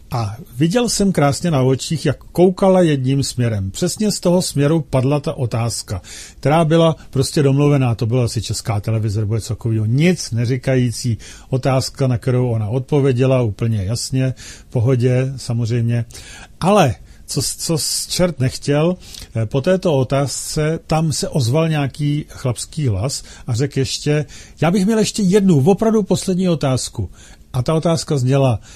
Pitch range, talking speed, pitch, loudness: 120-160 Hz, 150 wpm, 135 Hz, -17 LUFS